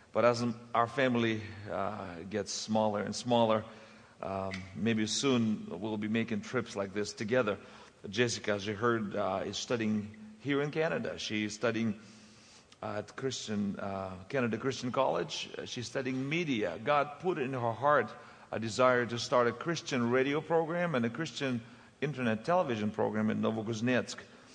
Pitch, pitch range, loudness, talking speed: 115 Hz, 105-130 Hz, -33 LUFS, 150 wpm